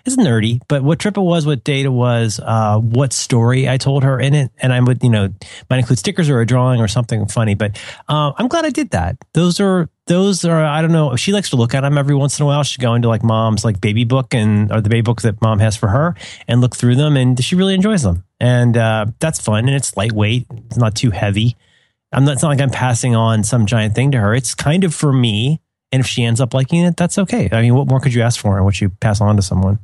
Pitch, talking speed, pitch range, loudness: 125 Hz, 275 wpm, 110-145 Hz, -15 LUFS